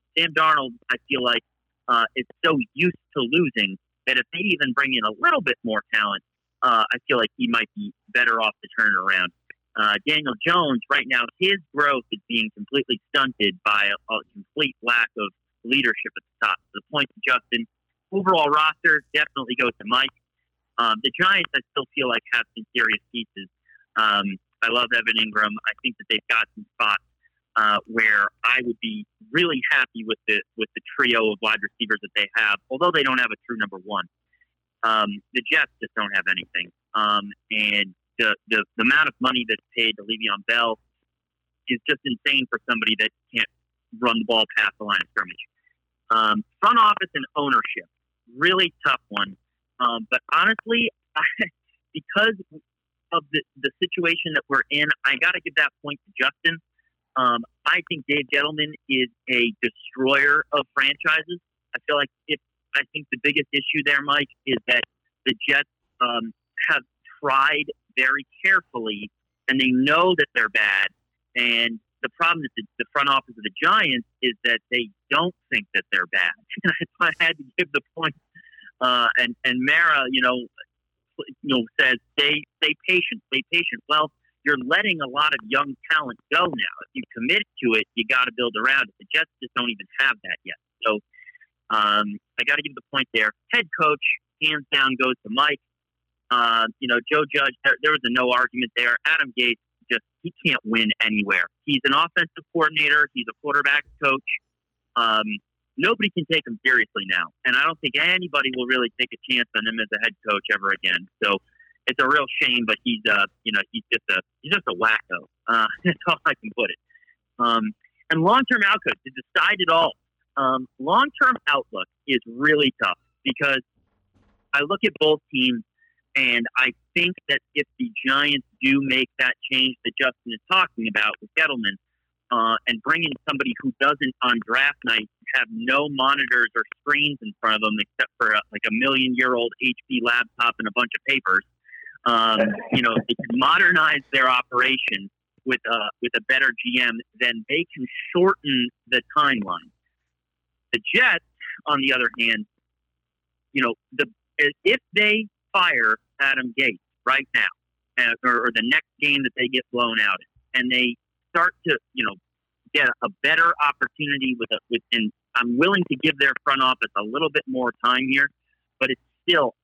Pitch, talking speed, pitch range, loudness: 130 Hz, 185 wpm, 115-160 Hz, -21 LUFS